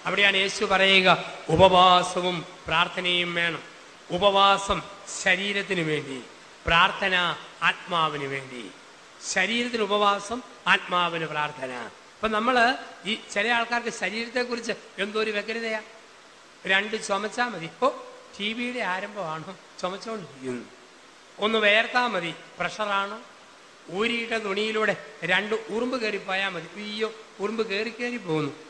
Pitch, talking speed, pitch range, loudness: 195 Hz, 105 wpm, 175-220 Hz, -24 LUFS